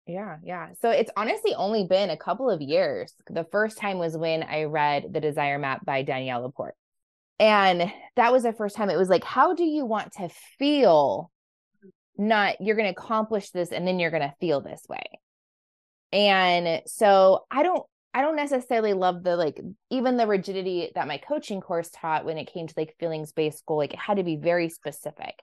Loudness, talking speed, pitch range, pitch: -25 LUFS, 195 wpm, 160-215 Hz, 185 Hz